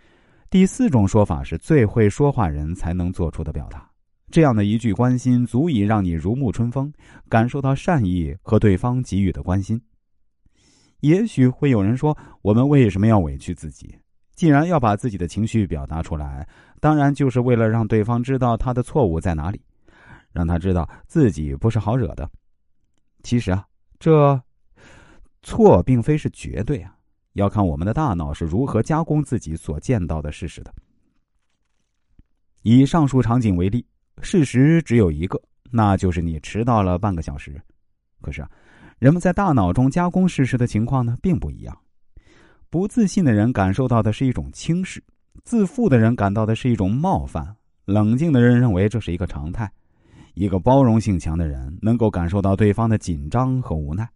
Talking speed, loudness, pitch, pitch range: 265 characters per minute, -20 LUFS, 110 Hz, 90-130 Hz